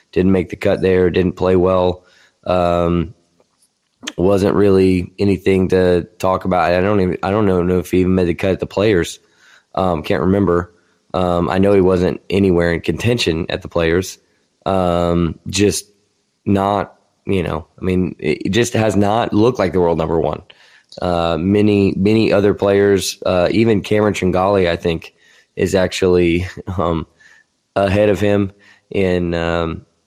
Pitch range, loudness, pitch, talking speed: 85-100 Hz, -16 LUFS, 95 Hz, 160 wpm